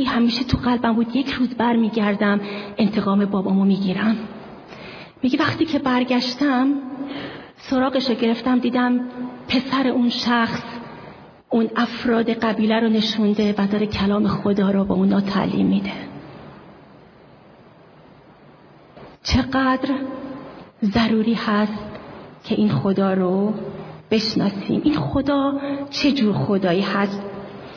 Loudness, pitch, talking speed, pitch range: -20 LUFS, 225 Hz, 110 wpm, 205-255 Hz